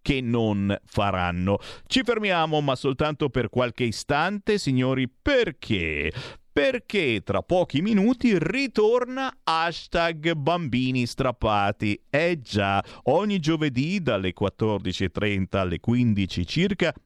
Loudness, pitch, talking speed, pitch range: -24 LUFS, 130 Hz, 100 wpm, 105-175 Hz